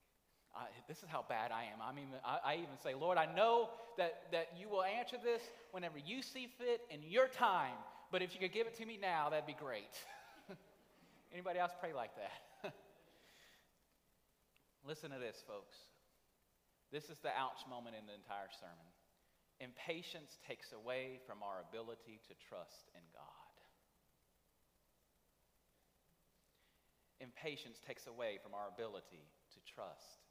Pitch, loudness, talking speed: 165 Hz, -44 LUFS, 150 wpm